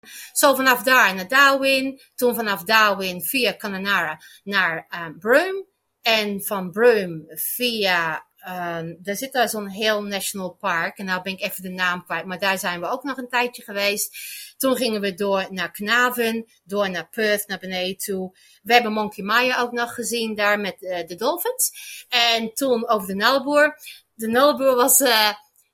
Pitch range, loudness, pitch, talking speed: 190-245 Hz, -21 LUFS, 215 Hz, 175 wpm